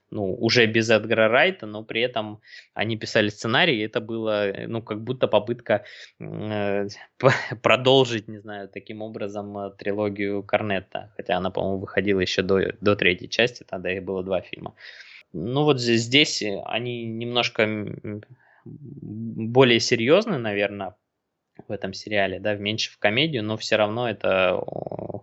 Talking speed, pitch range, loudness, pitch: 140 wpm, 100-115 Hz, -23 LUFS, 110 Hz